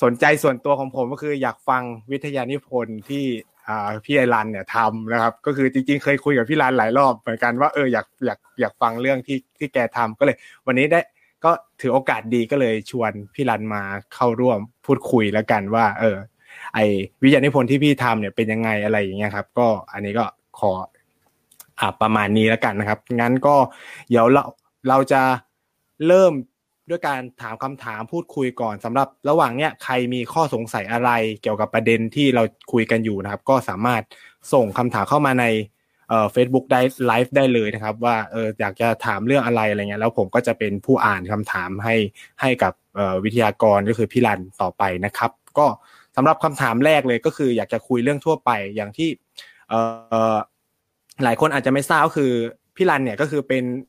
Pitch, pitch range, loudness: 120 Hz, 110-135 Hz, -20 LUFS